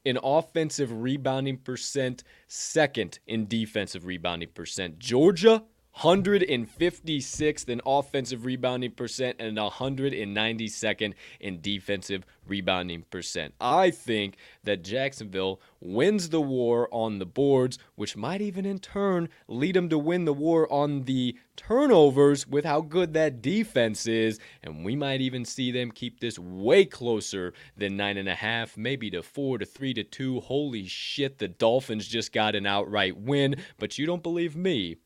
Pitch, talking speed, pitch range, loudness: 125 Hz, 150 wpm, 105-145 Hz, -27 LUFS